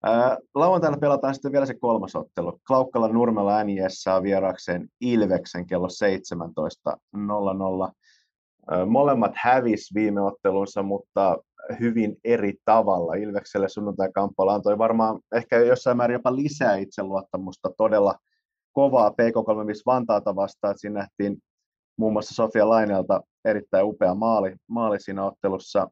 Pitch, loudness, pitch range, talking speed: 105 Hz, -23 LUFS, 100-120 Hz, 125 wpm